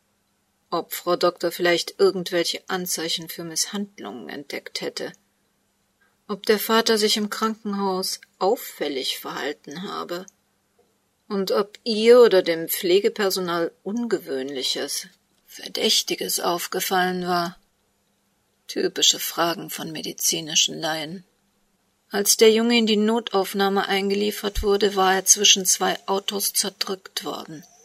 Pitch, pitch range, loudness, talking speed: 195 Hz, 175-215 Hz, -22 LUFS, 105 wpm